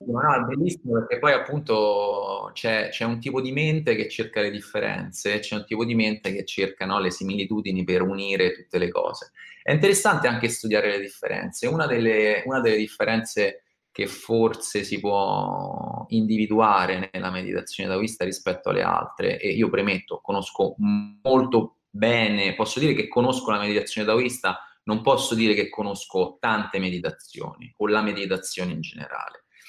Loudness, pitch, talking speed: -24 LUFS, 115 Hz, 160 wpm